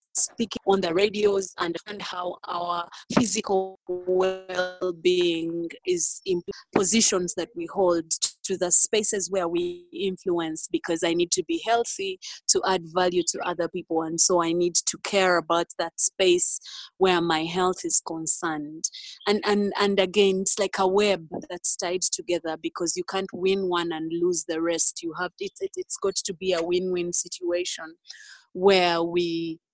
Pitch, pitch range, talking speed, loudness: 180 Hz, 170-200 Hz, 170 wpm, -24 LUFS